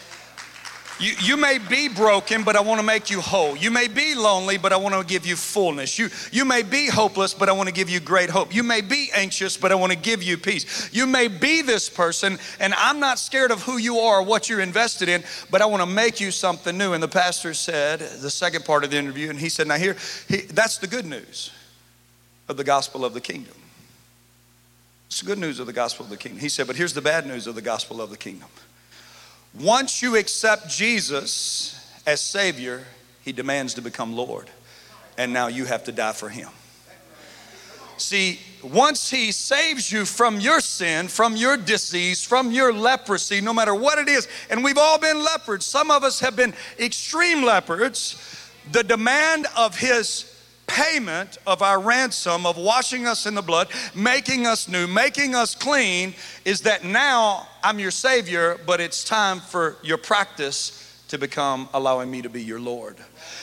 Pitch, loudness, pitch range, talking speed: 195 Hz, -21 LUFS, 155-235 Hz, 200 wpm